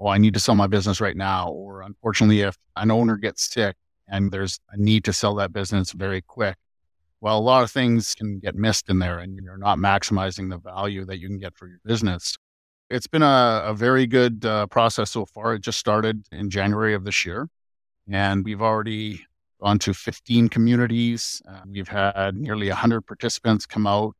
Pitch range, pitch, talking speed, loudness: 95-110 Hz, 100 Hz, 205 wpm, -22 LUFS